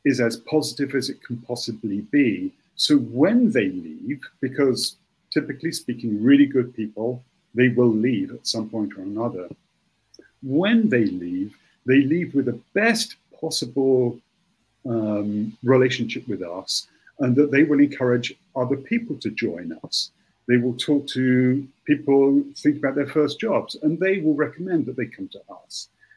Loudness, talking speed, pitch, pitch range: -22 LUFS, 155 wpm, 140 Hz, 125-160 Hz